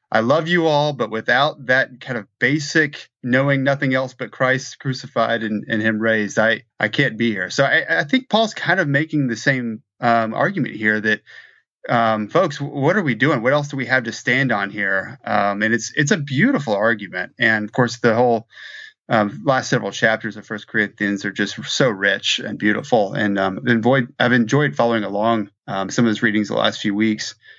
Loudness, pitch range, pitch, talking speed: -19 LUFS, 110-135 Hz, 115 Hz, 210 wpm